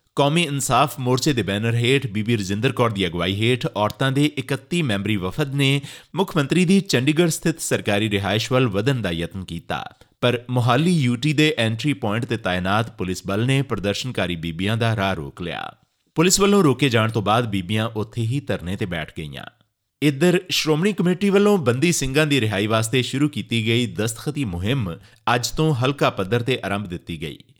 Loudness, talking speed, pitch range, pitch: -21 LUFS, 175 wpm, 100-145 Hz, 120 Hz